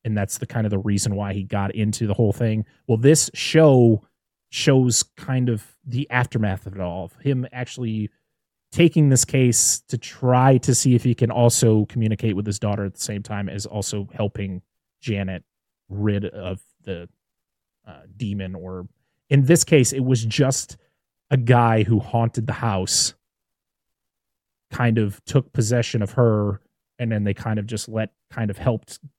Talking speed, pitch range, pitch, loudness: 175 wpm, 100-125 Hz, 115 Hz, -21 LUFS